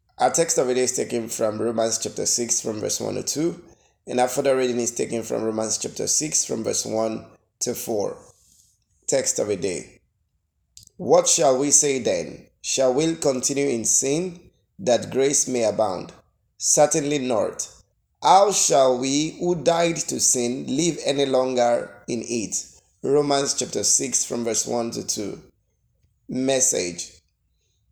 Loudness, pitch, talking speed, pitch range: -21 LUFS, 125 Hz, 155 wpm, 110-145 Hz